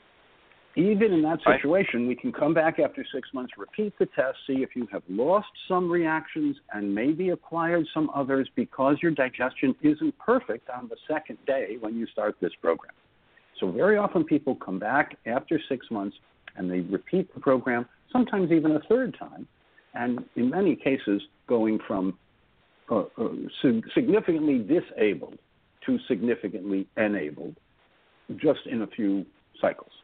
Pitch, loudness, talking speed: 145 Hz, -27 LUFS, 150 wpm